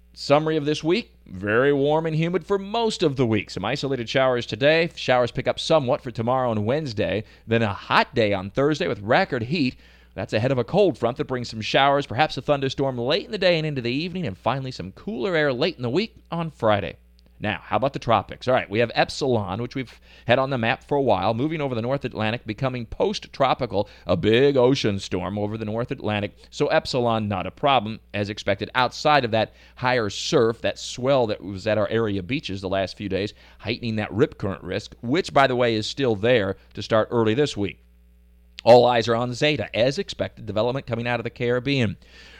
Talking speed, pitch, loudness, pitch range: 220 wpm, 120 Hz, -23 LUFS, 105-140 Hz